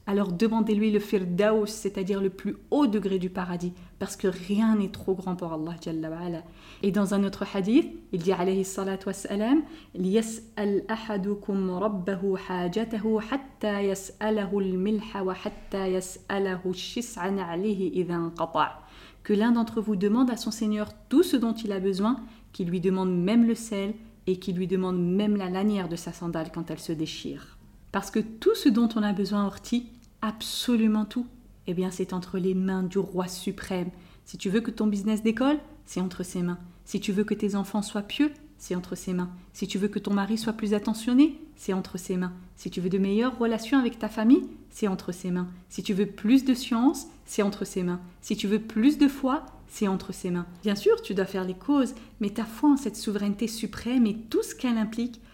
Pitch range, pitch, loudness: 185-225 Hz, 205 Hz, -28 LUFS